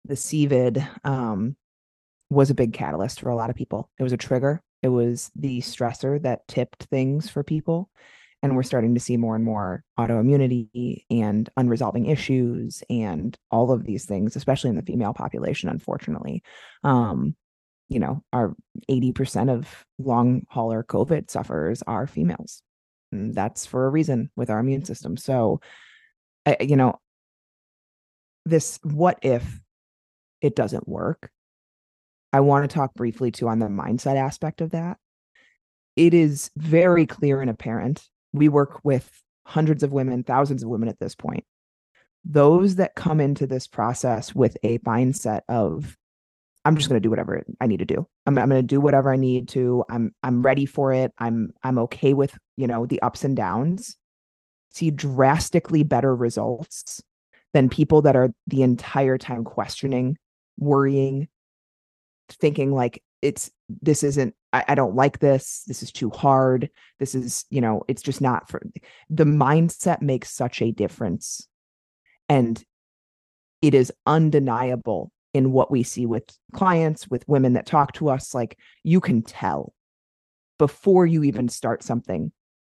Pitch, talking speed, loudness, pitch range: 130 Hz, 160 wpm, -23 LUFS, 120-145 Hz